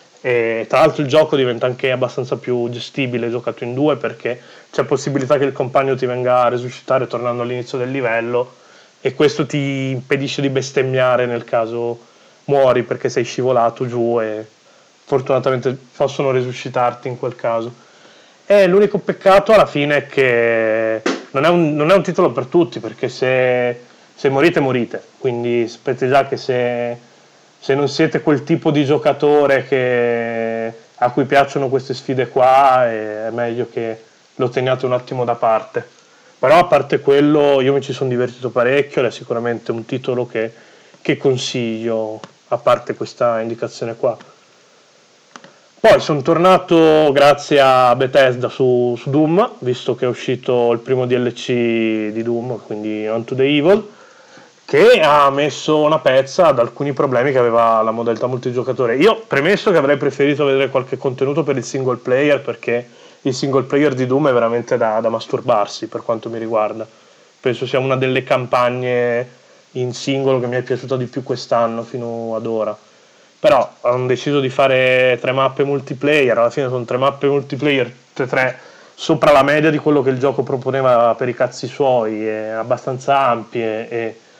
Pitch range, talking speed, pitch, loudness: 120-140 Hz, 165 wpm, 130 Hz, -16 LUFS